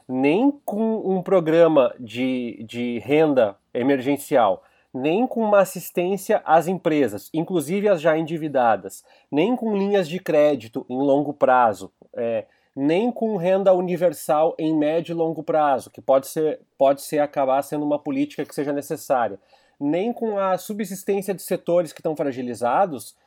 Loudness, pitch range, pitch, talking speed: -22 LUFS, 145-195 Hz, 165 Hz, 145 wpm